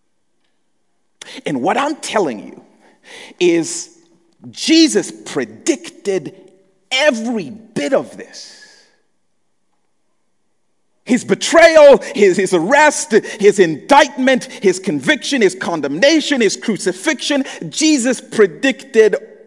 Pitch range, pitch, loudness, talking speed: 215-325 Hz, 280 Hz, -14 LUFS, 85 wpm